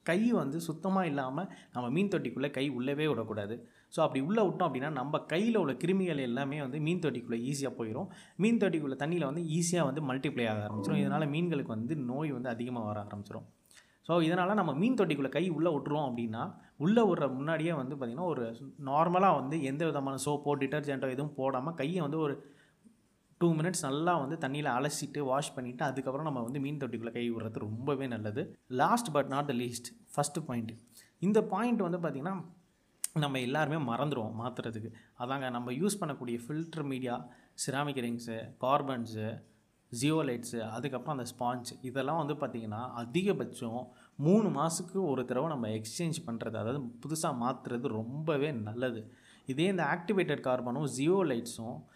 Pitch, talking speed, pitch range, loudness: 140 Hz, 155 wpm, 120-165 Hz, -33 LUFS